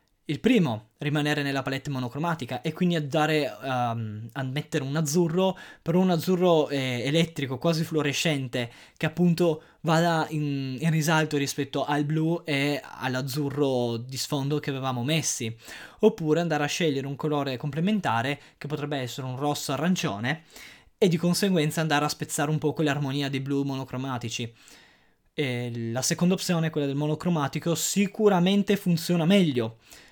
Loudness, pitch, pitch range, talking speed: -26 LUFS, 150 Hz, 135-165 Hz, 140 wpm